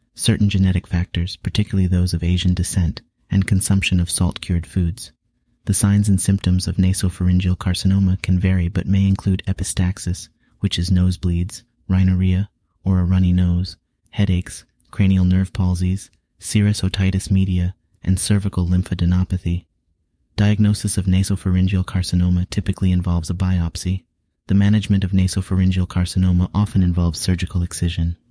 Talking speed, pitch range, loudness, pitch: 130 wpm, 90-95 Hz, -19 LUFS, 95 Hz